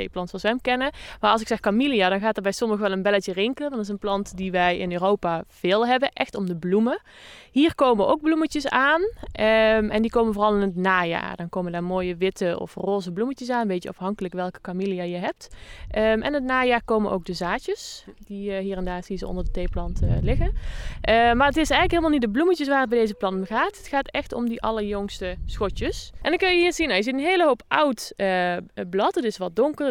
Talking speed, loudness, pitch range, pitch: 250 wpm, -23 LUFS, 190-265 Hz, 215 Hz